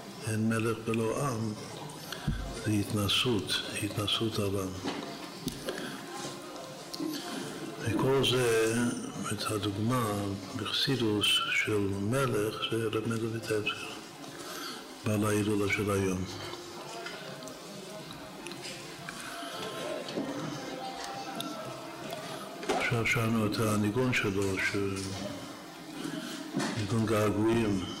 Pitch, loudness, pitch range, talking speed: 105 Hz, -32 LUFS, 100-115 Hz, 60 wpm